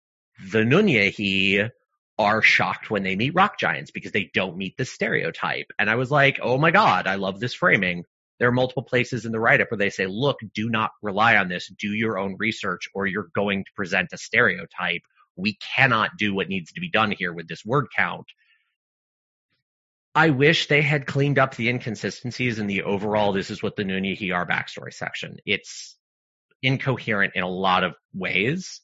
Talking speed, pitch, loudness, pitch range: 190 wpm, 110 Hz, -22 LUFS, 95-135 Hz